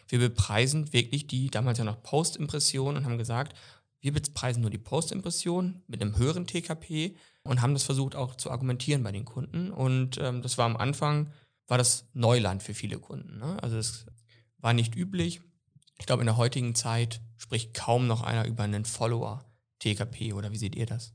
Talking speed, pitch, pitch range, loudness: 190 wpm, 125 Hz, 115-140 Hz, -29 LUFS